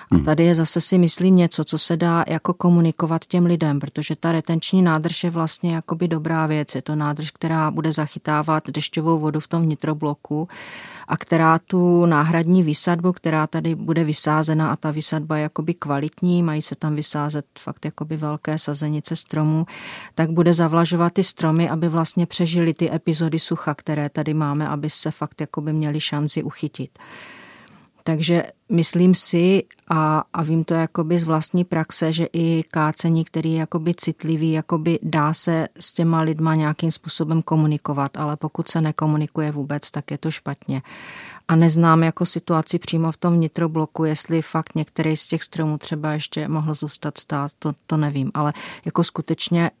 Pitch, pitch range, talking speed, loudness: 160 Hz, 155-170 Hz, 170 wpm, -20 LUFS